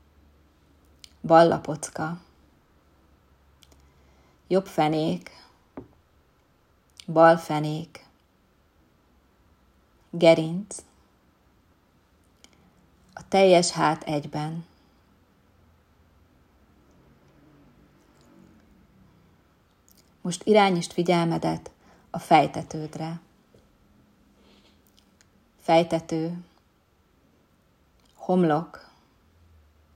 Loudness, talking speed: -23 LUFS, 35 wpm